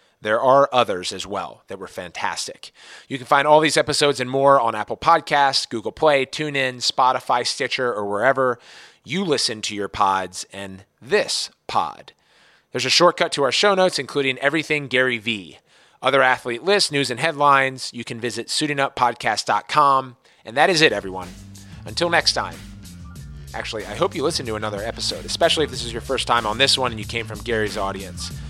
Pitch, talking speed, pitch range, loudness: 125 Hz, 185 wpm, 105-140 Hz, -20 LUFS